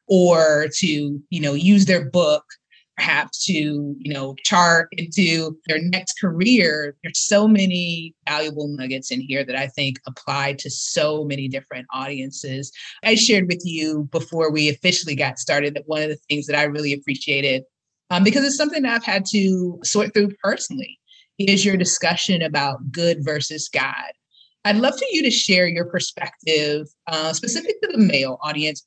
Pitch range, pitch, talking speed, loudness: 145-195 Hz, 160 Hz, 170 wpm, -20 LUFS